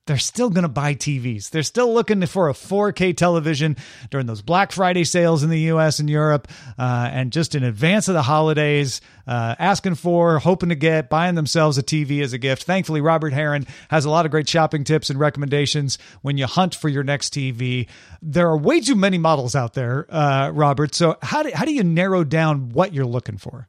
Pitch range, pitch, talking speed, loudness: 140-170 Hz, 155 Hz, 215 wpm, -19 LUFS